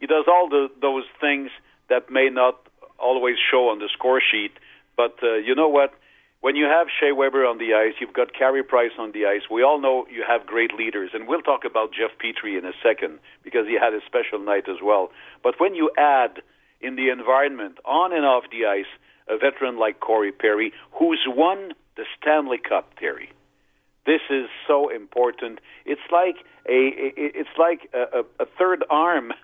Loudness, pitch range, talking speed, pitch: -21 LUFS, 125-175 Hz, 195 wpm, 135 Hz